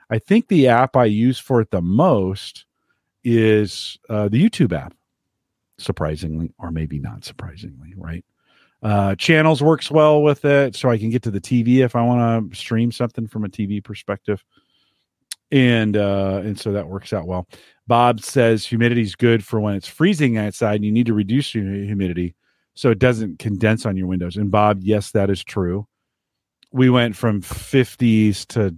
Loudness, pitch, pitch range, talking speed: -19 LUFS, 110 Hz, 100-120 Hz, 180 wpm